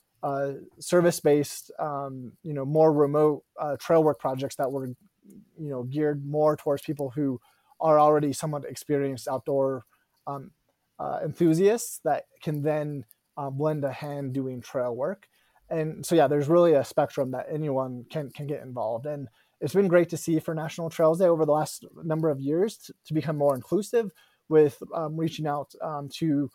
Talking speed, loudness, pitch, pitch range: 175 wpm, -26 LUFS, 150 Hz, 140-160 Hz